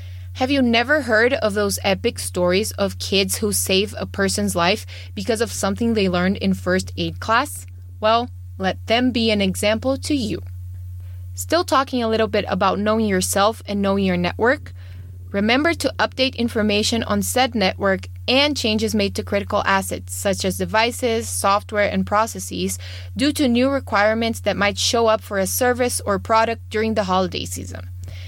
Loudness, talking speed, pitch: -20 LUFS, 170 wpm, 195 Hz